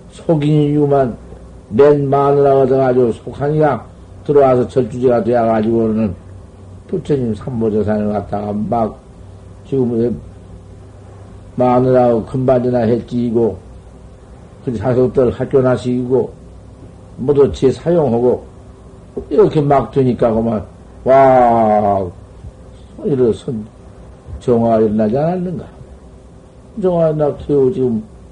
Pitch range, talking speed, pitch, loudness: 100-135 Hz, 225 characters per minute, 120 Hz, -14 LUFS